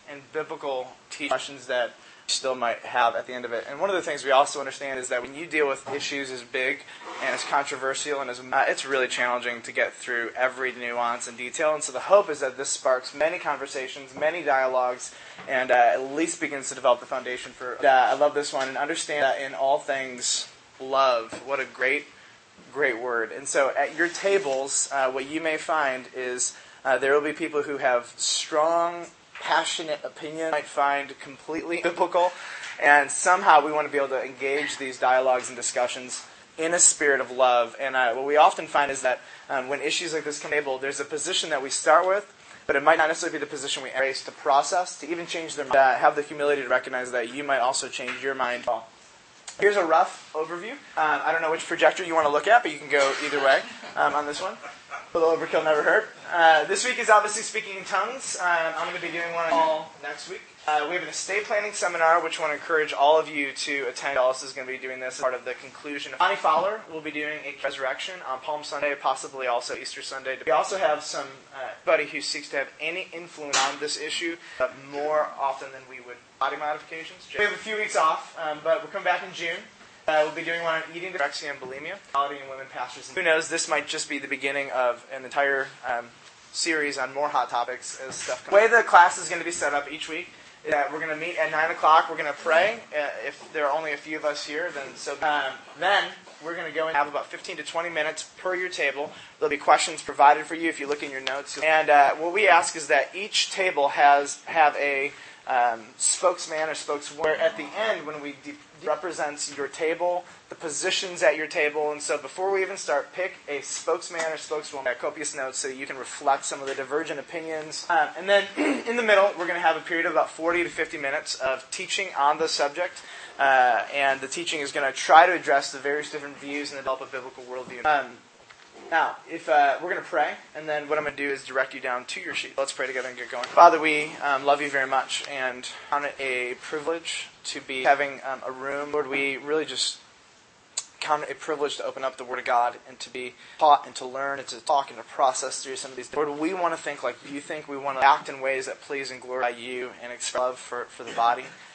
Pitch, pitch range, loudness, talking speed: 145 Hz, 135-160 Hz, -25 LUFS, 240 wpm